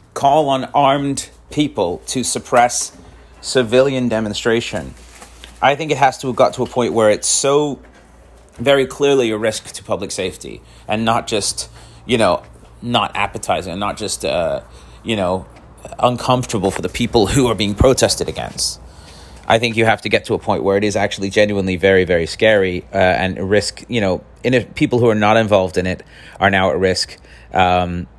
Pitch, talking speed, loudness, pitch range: 105 Hz, 185 wpm, -17 LUFS, 90-120 Hz